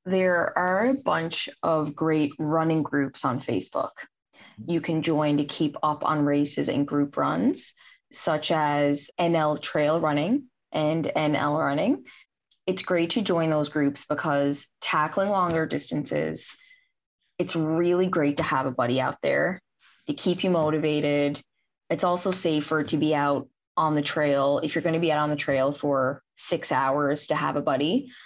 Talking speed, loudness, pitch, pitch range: 165 wpm, -25 LUFS, 155 Hz, 145-170 Hz